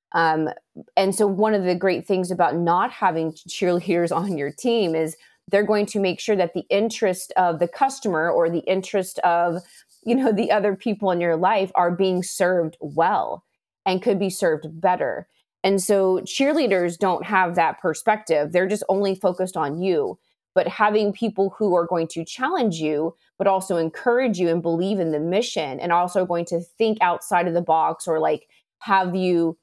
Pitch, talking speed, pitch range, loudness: 185 Hz, 185 wpm, 170-205 Hz, -22 LUFS